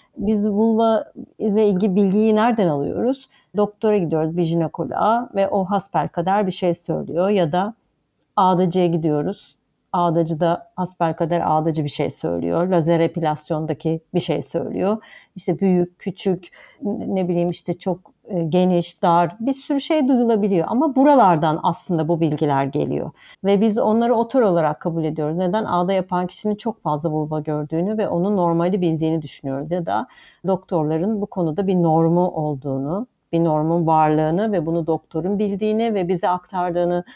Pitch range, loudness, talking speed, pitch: 165-205 Hz, -20 LUFS, 150 wpm, 180 Hz